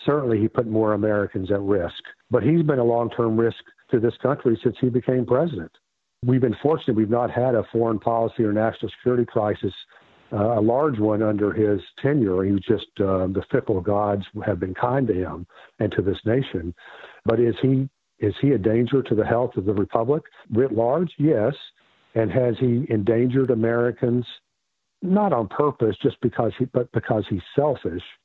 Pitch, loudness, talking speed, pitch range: 115 Hz, -22 LUFS, 185 wpm, 105-125 Hz